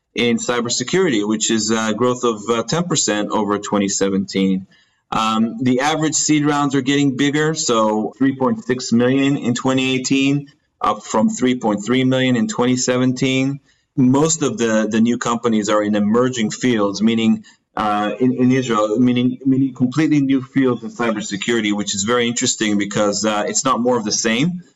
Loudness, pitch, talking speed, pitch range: -17 LUFS, 125 Hz, 155 wpm, 110-135 Hz